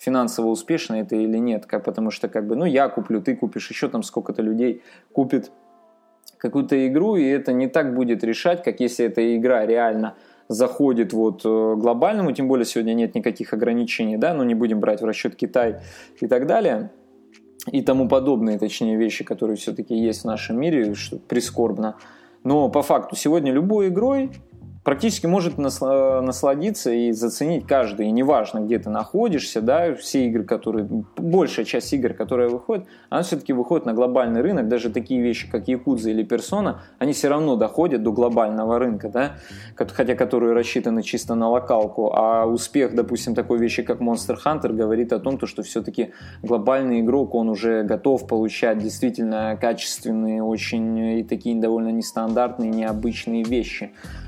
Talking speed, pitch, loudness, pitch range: 165 wpm, 115 Hz, -22 LUFS, 110-130 Hz